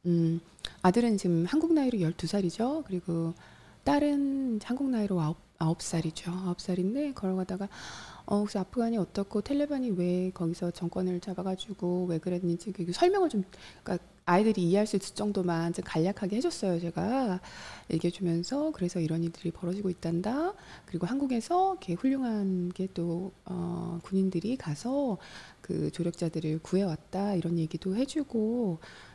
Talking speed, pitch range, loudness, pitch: 340 characters per minute, 175-225 Hz, -31 LUFS, 185 Hz